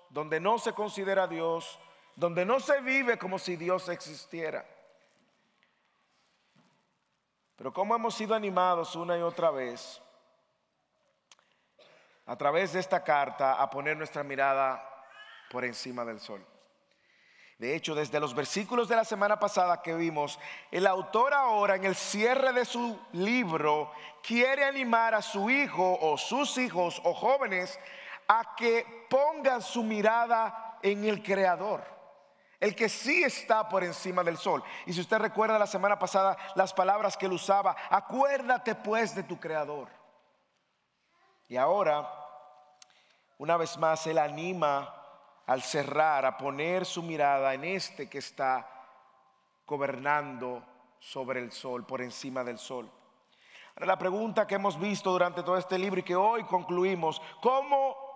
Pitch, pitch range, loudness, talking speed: 185 Hz, 150-220 Hz, -29 LUFS, 140 wpm